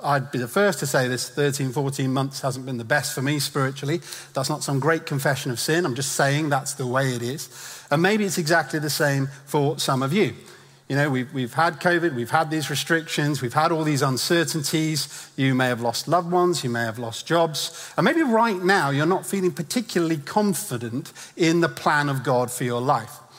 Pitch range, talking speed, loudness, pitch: 135-165 Hz, 215 wpm, -23 LUFS, 145 Hz